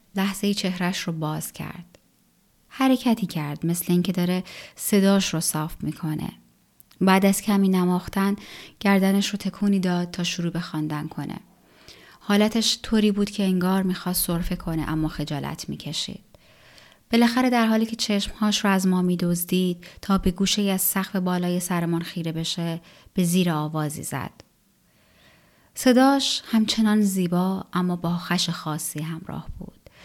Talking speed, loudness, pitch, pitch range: 140 wpm, -23 LUFS, 185 Hz, 170-200 Hz